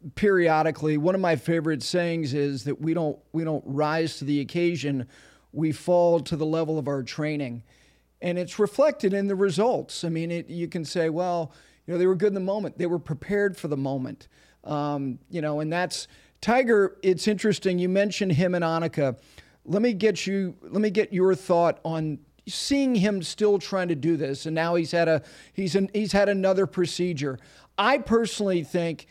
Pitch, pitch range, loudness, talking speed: 170 Hz, 155-195 Hz, -25 LUFS, 195 wpm